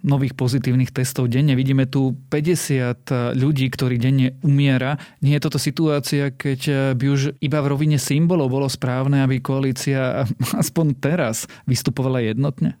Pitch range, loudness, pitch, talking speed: 130-145 Hz, -20 LUFS, 135 Hz, 140 wpm